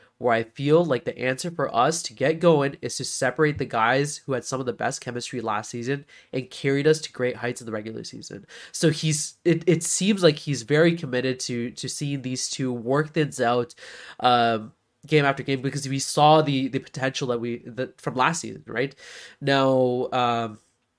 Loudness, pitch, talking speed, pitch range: -24 LUFS, 135 Hz, 205 wpm, 120-150 Hz